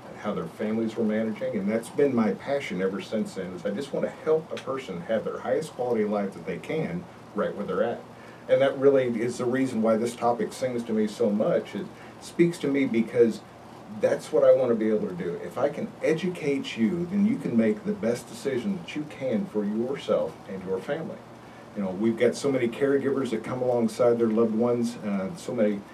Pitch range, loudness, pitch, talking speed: 110-150 Hz, -27 LUFS, 120 Hz, 225 wpm